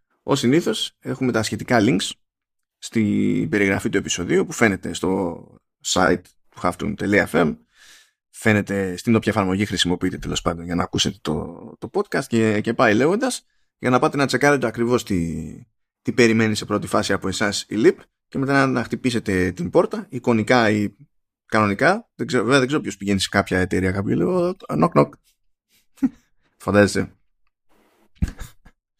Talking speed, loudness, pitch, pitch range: 150 wpm, -21 LUFS, 110 Hz, 95-125 Hz